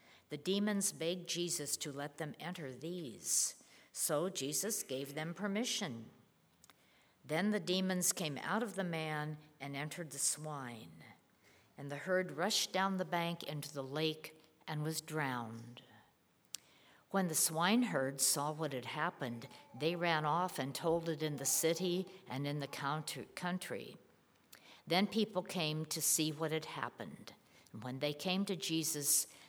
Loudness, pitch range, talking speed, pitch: -37 LUFS, 145-180 Hz, 150 wpm, 155 Hz